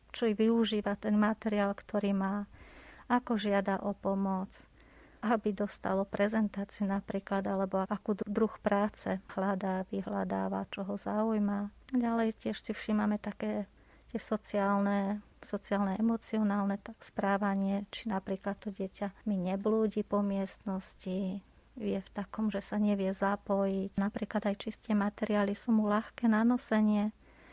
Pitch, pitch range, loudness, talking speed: 205 Hz, 195-215 Hz, -33 LUFS, 125 wpm